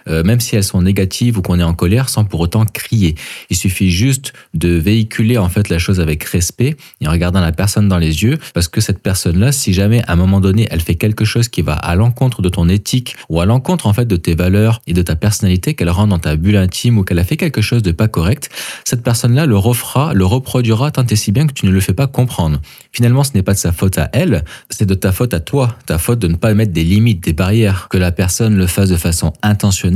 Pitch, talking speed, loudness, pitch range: 100 Hz, 260 wpm, -14 LUFS, 90-115 Hz